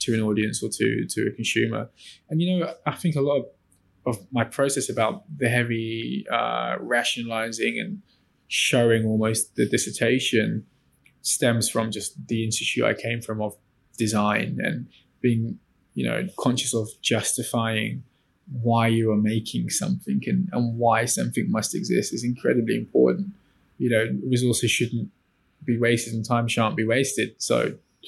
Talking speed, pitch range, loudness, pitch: 155 wpm, 110-130 Hz, -24 LUFS, 115 Hz